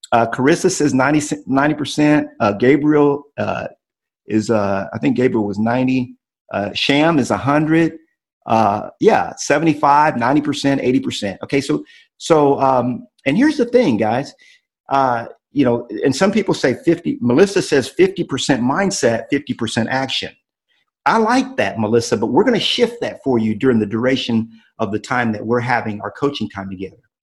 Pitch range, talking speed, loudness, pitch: 115-155 Hz, 160 wpm, -17 LUFS, 135 Hz